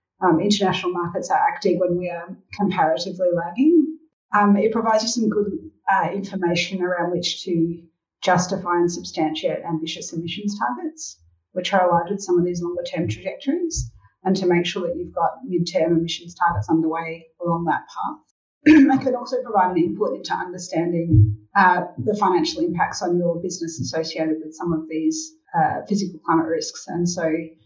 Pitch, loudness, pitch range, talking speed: 175 Hz, -21 LUFS, 165-205 Hz, 170 wpm